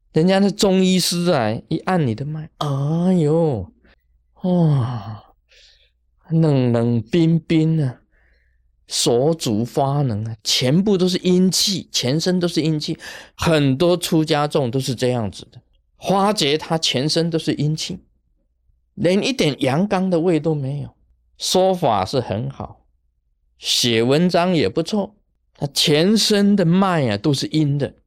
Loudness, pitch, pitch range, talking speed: -18 LUFS, 150 Hz, 115-175 Hz, 190 characters per minute